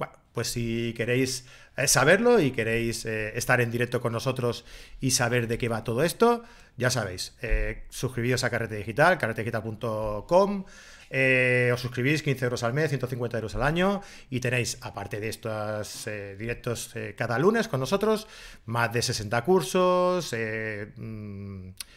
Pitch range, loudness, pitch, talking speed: 115-135 Hz, -26 LUFS, 120 Hz, 155 wpm